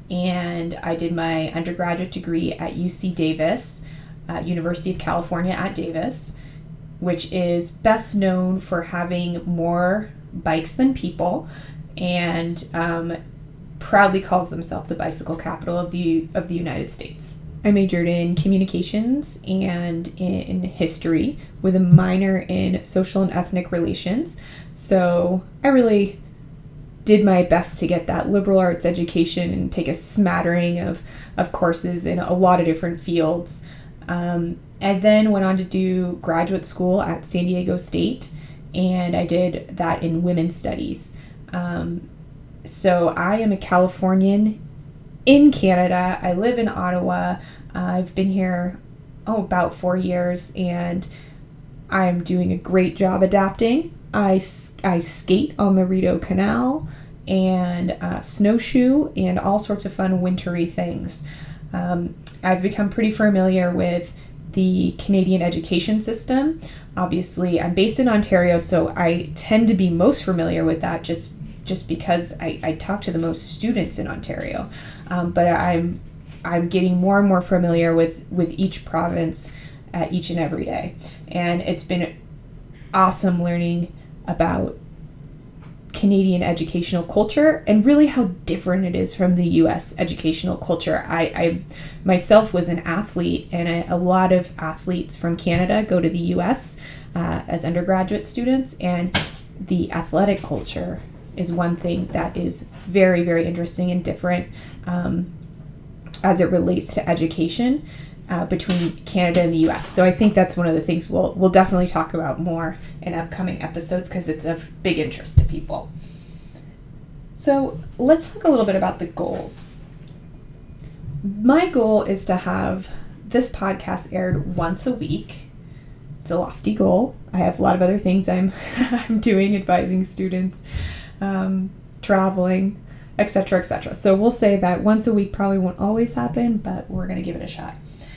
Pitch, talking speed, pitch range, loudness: 175 Hz, 150 wpm, 160-190 Hz, -21 LUFS